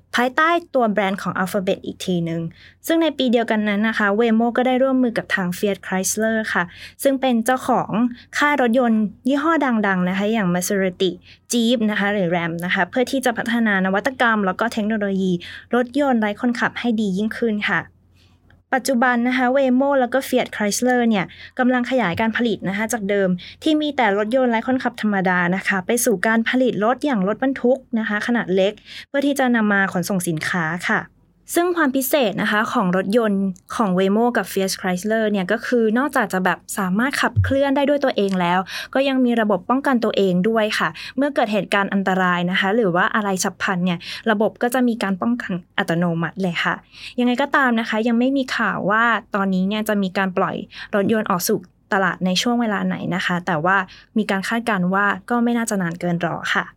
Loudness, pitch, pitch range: -20 LUFS, 215 Hz, 190-245 Hz